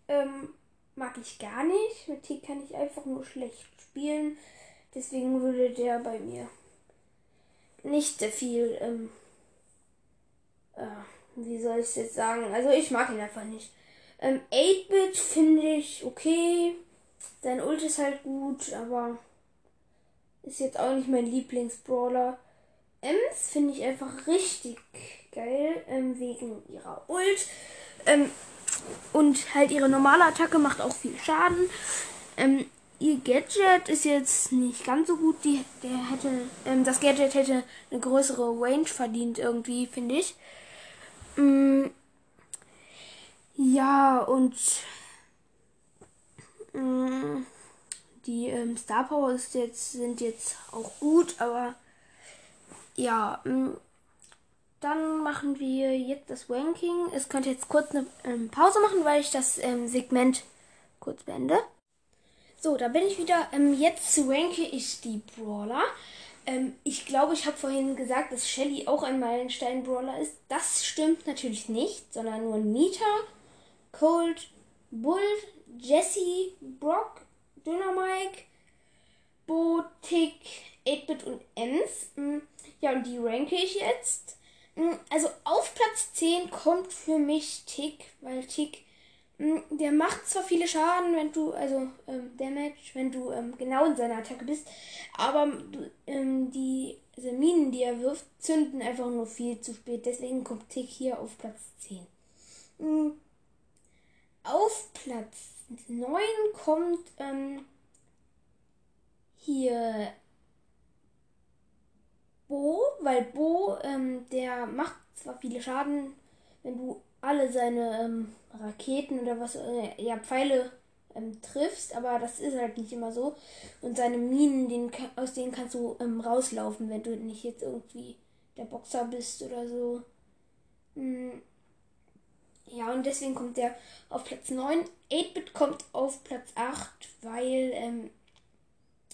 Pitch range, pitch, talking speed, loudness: 245-300 Hz, 265 Hz, 130 wpm, -29 LUFS